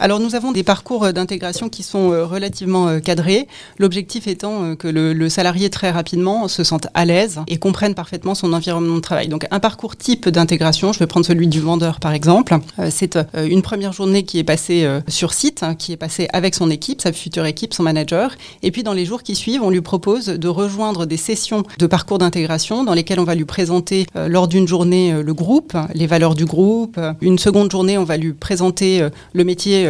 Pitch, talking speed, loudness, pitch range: 180 Hz, 205 wpm, -17 LUFS, 165-200 Hz